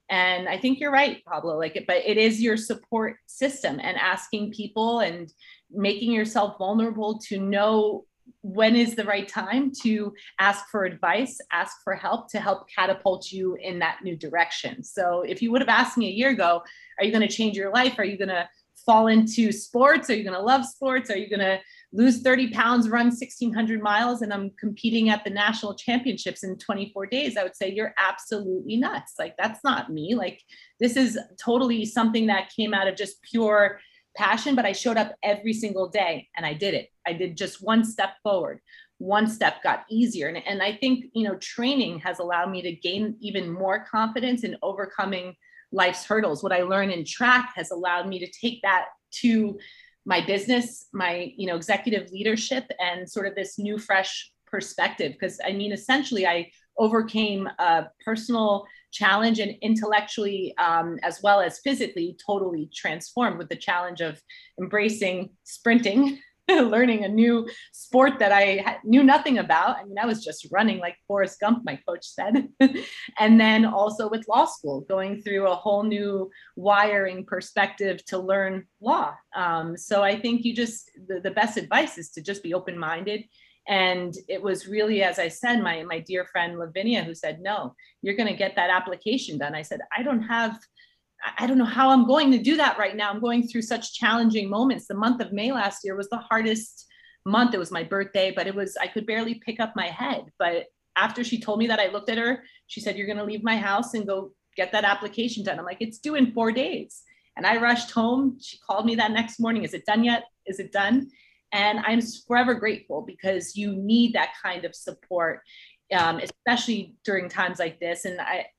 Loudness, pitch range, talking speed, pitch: -24 LUFS, 190-235 Hz, 200 wpm, 210 Hz